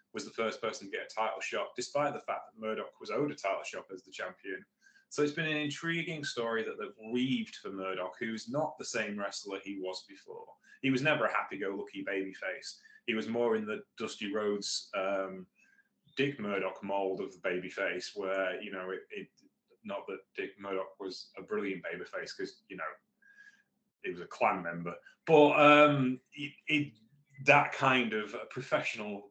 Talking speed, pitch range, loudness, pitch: 190 wpm, 100-150 Hz, -33 LUFS, 120 Hz